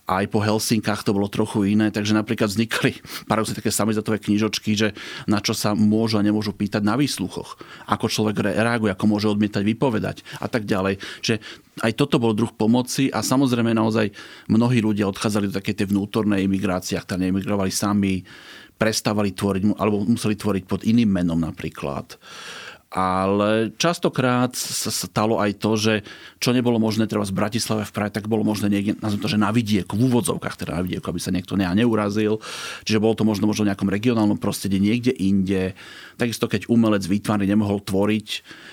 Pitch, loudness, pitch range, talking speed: 105 Hz, -22 LUFS, 100-110 Hz, 175 wpm